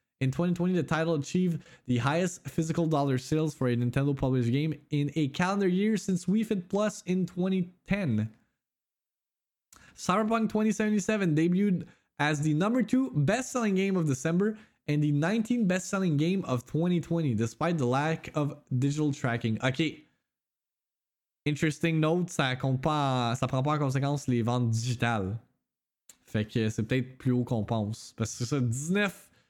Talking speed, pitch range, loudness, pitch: 150 wpm, 130-180 Hz, -29 LUFS, 155 Hz